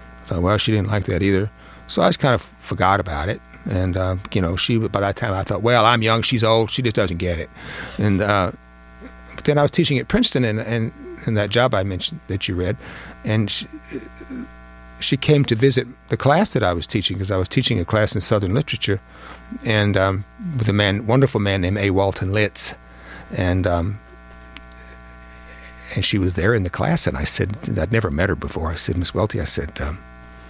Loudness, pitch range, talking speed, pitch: -20 LUFS, 80-115 Hz, 220 wpm, 100 Hz